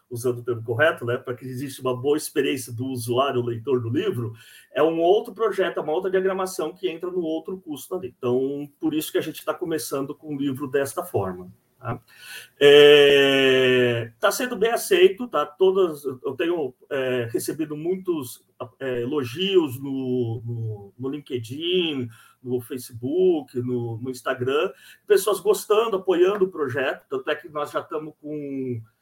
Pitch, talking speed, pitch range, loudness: 145 Hz, 165 wpm, 125-190 Hz, -23 LUFS